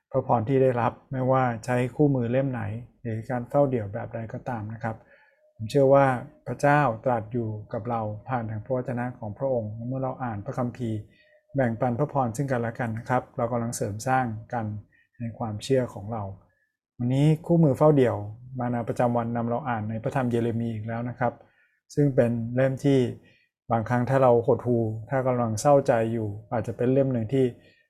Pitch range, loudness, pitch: 115-130 Hz, -26 LUFS, 120 Hz